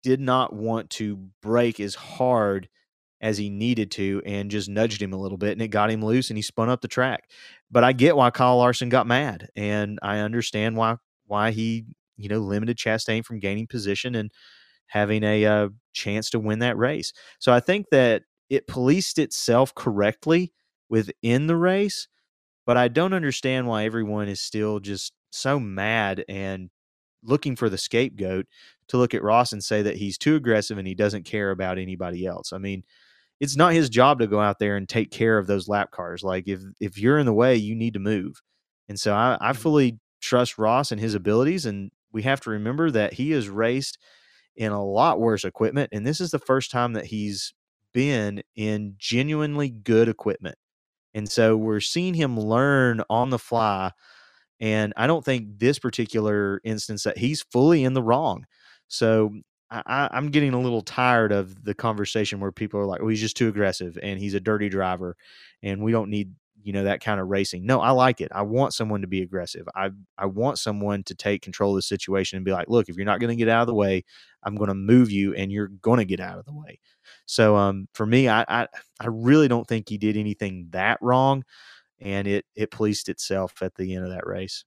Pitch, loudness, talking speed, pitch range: 110 Hz, -24 LUFS, 210 wpm, 100-125 Hz